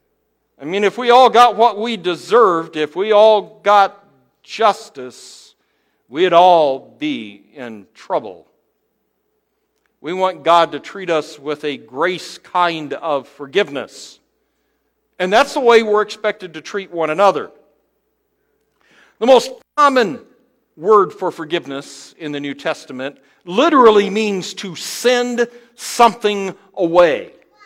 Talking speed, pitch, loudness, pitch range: 125 wpm, 200 Hz, -15 LUFS, 165-235 Hz